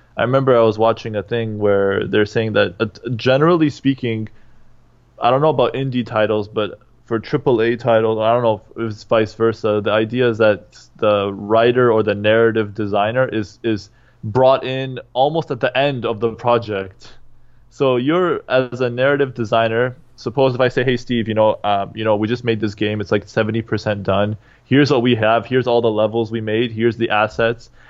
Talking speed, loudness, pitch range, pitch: 200 wpm, -18 LUFS, 110-125 Hz, 115 Hz